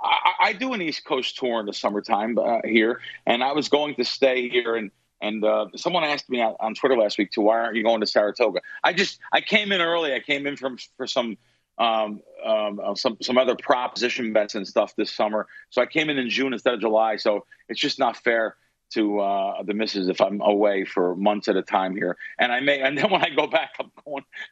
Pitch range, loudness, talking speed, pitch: 105-145 Hz, -23 LUFS, 235 wpm, 115 Hz